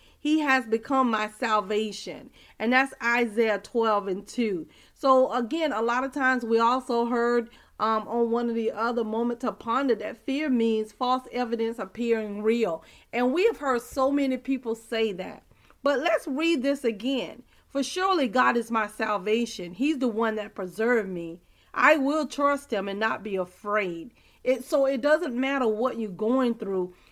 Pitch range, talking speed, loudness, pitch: 220-265 Hz, 175 wpm, -26 LUFS, 235 Hz